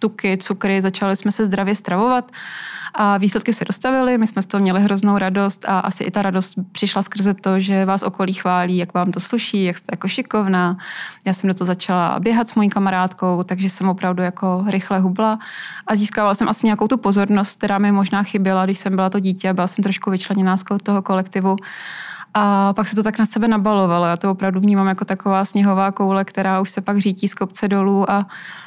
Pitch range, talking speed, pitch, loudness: 190-205 Hz, 210 wpm, 195 Hz, -18 LUFS